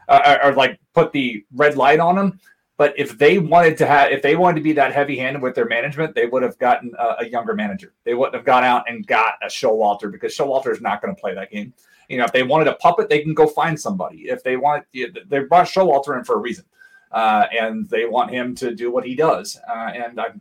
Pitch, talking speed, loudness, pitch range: 145 Hz, 255 wpm, -18 LUFS, 125-180 Hz